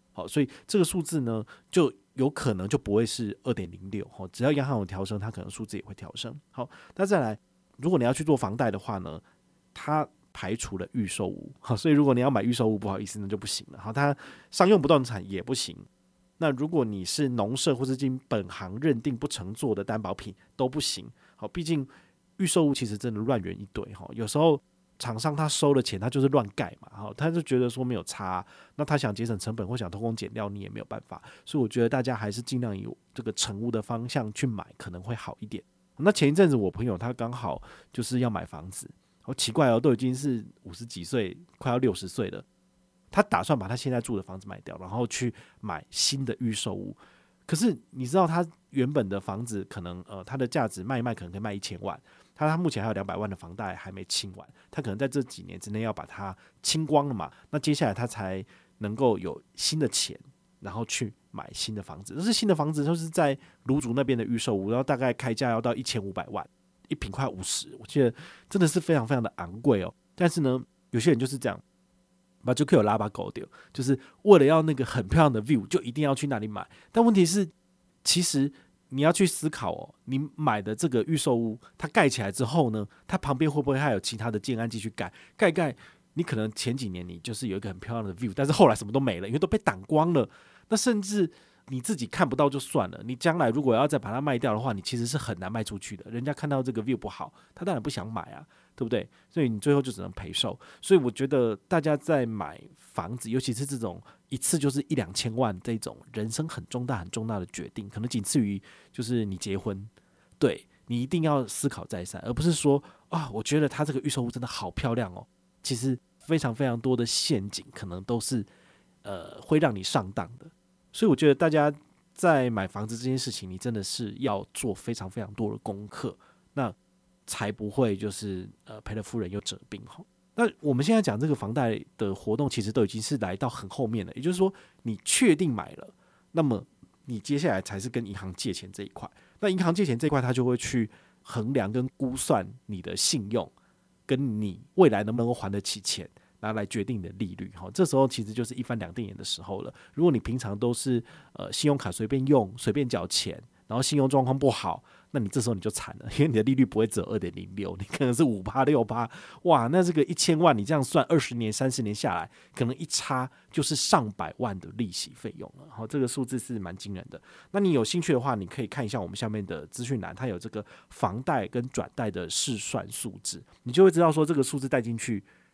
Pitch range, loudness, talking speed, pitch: 105-145 Hz, -28 LUFS, 330 characters per minute, 120 Hz